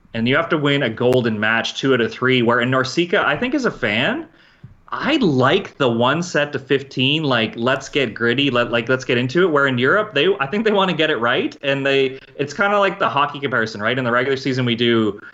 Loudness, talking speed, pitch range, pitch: -18 LUFS, 250 wpm, 120-145 Hz, 135 Hz